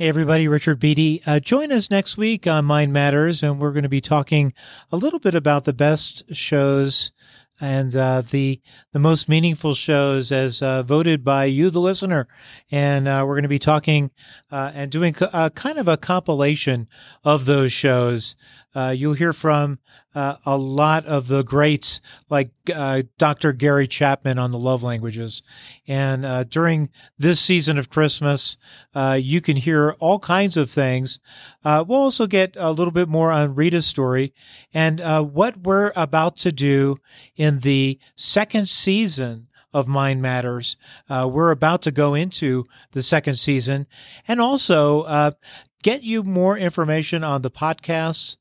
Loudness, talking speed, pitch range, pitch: -19 LUFS, 170 wpm, 135-160 Hz, 150 Hz